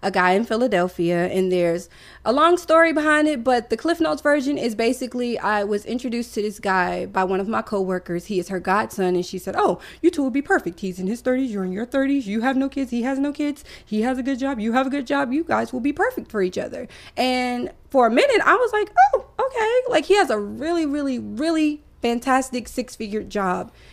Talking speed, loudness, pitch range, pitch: 240 wpm, -21 LUFS, 200-290 Hz, 245 Hz